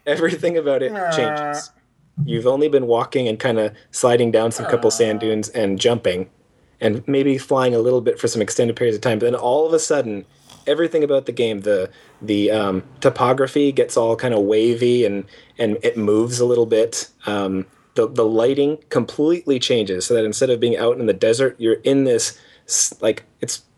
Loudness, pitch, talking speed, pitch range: -19 LUFS, 125 Hz, 195 wpm, 110-145 Hz